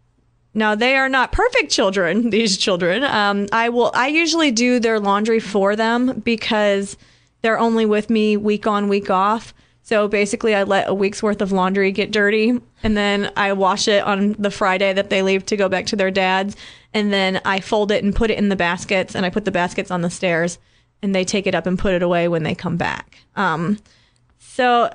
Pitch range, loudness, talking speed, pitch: 190-220 Hz, -18 LUFS, 215 wpm, 205 Hz